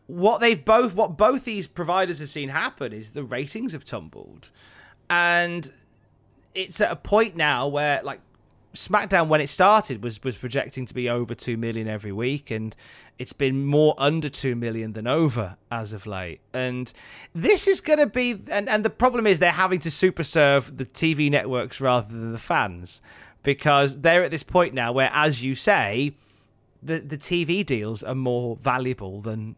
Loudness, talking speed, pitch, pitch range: -23 LUFS, 185 wpm, 140 Hz, 120-175 Hz